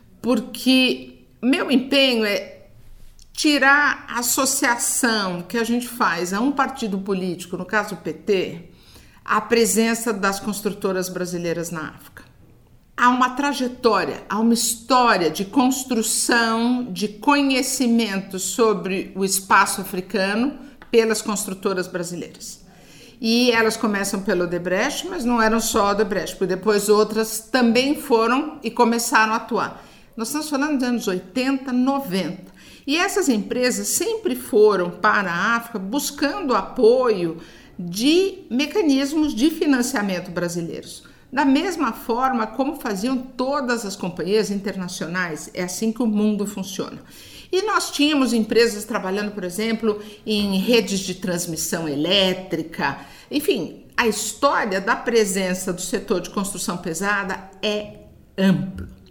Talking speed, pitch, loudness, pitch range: 125 wpm, 220 Hz, -21 LUFS, 190-255 Hz